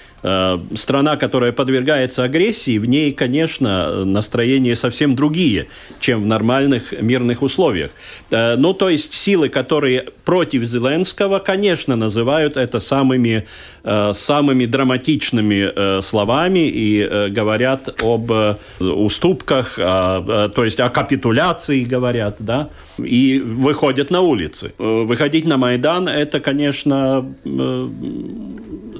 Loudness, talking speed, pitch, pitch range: -16 LUFS, 100 wpm, 130 Hz, 110-145 Hz